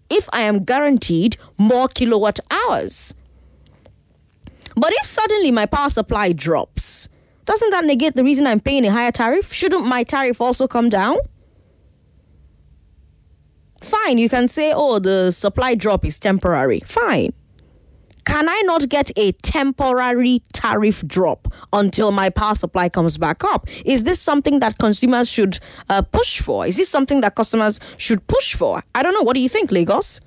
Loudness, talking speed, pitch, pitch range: -17 LUFS, 160 wpm, 235 Hz, 195-280 Hz